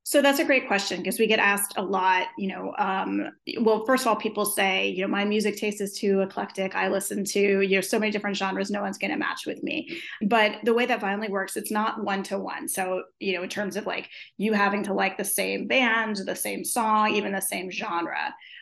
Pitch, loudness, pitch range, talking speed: 205 Hz, -25 LUFS, 195-220 Hz, 240 wpm